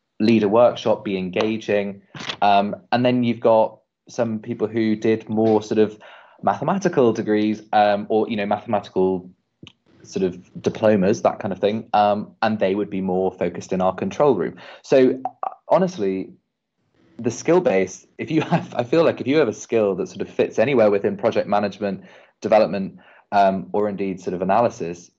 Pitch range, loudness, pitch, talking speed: 100-115 Hz, -21 LUFS, 105 Hz, 175 wpm